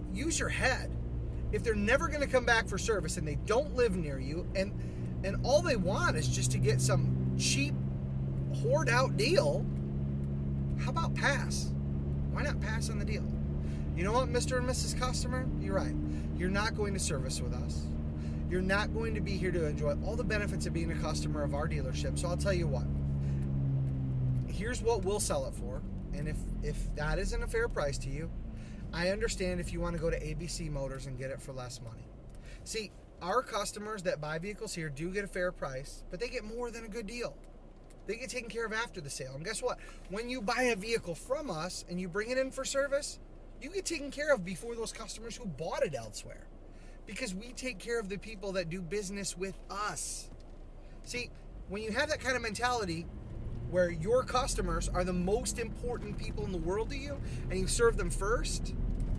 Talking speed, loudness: 210 wpm, -34 LUFS